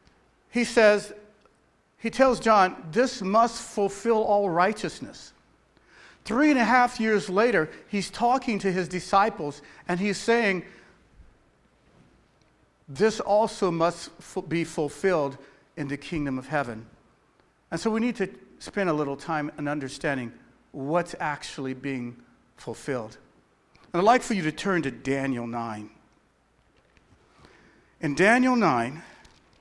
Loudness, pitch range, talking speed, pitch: -25 LUFS, 145-220 Hz, 125 wpm, 185 Hz